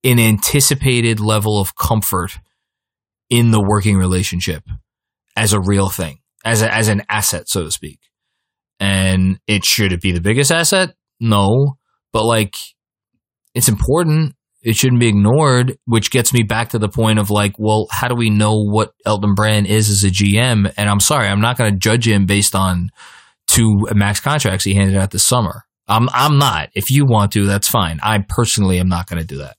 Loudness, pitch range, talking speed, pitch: -15 LUFS, 100-115 Hz, 195 wpm, 105 Hz